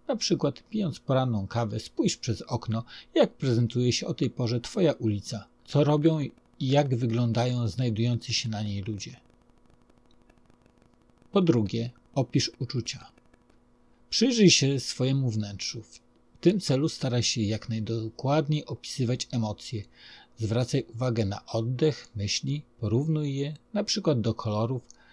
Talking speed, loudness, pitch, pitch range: 130 wpm, -28 LUFS, 120 Hz, 115-140 Hz